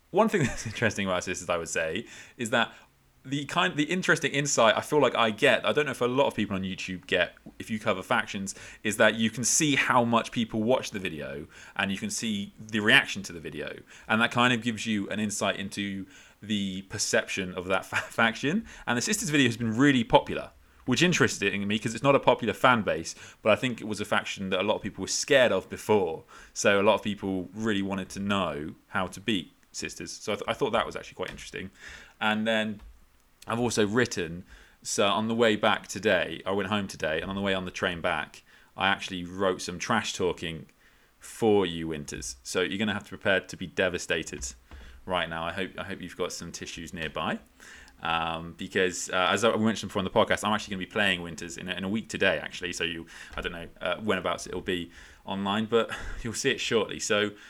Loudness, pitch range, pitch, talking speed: -27 LUFS, 95-115 Hz, 105 Hz, 235 wpm